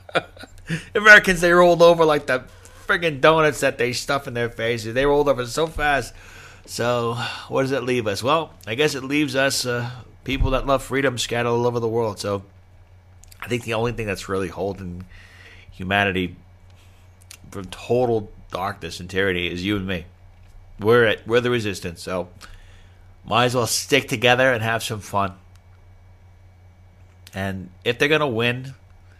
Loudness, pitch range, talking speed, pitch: -20 LUFS, 90-125 Hz, 165 wpm, 105 Hz